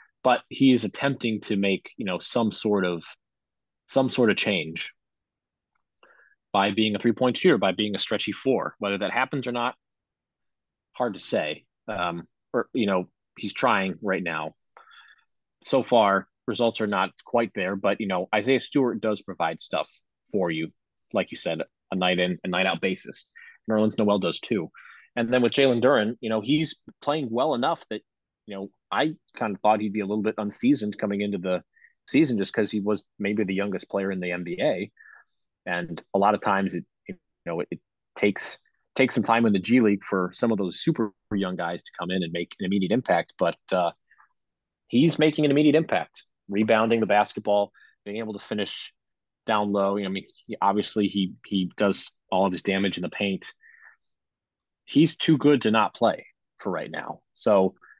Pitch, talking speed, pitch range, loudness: 105 Hz, 190 wpm, 95-115 Hz, -25 LUFS